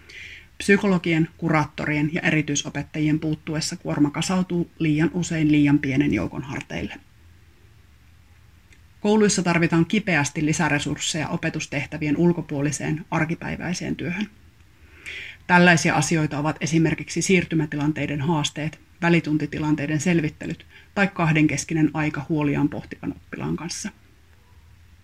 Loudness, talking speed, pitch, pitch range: -22 LUFS, 85 wpm, 155 Hz, 145-170 Hz